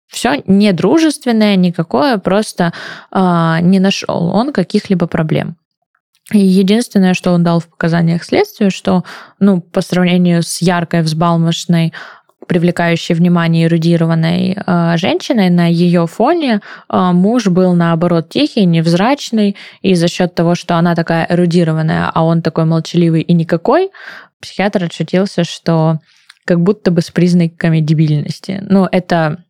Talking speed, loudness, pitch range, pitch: 130 wpm, -13 LUFS, 170-195 Hz, 175 Hz